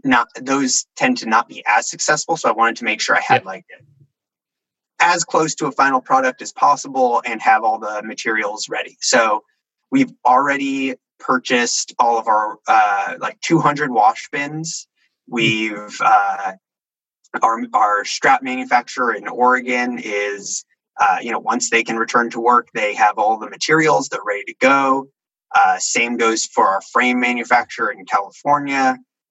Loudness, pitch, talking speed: -17 LUFS, 140 Hz, 165 wpm